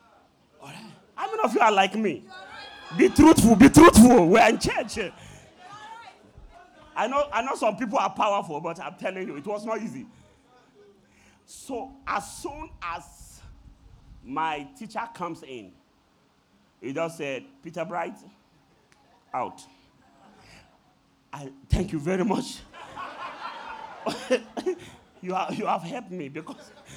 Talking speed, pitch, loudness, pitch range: 125 wpm, 215 Hz, -22 LUFS, 165-275 Hz